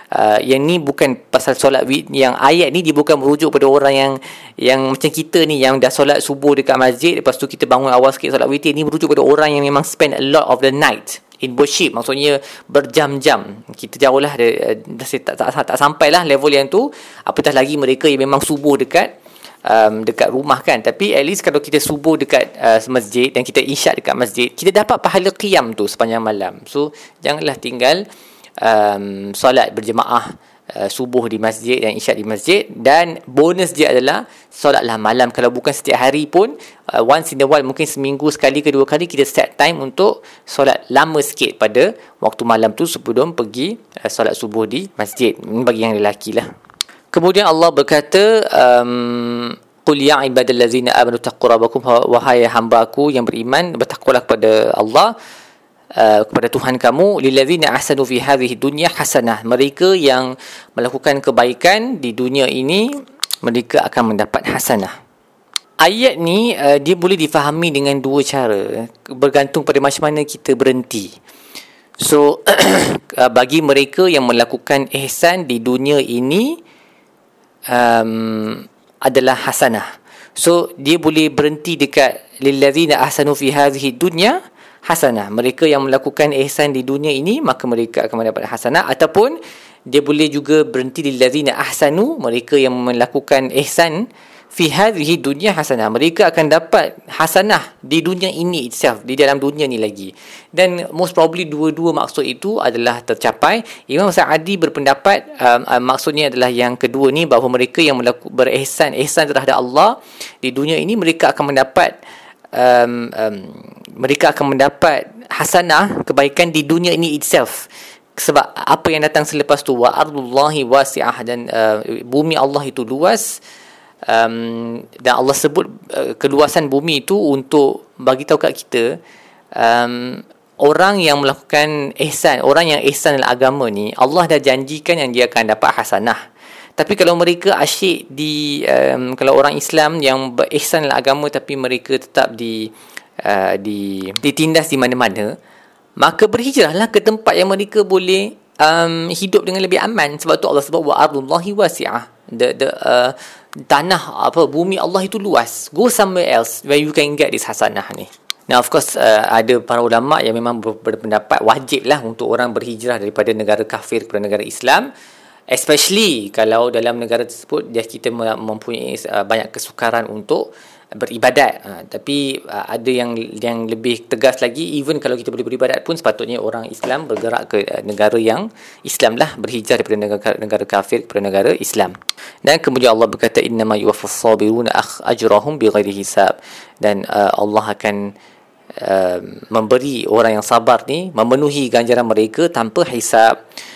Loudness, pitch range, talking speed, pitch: -14 LUFS, 120-155 Hz, 155 wpm, 140 Hz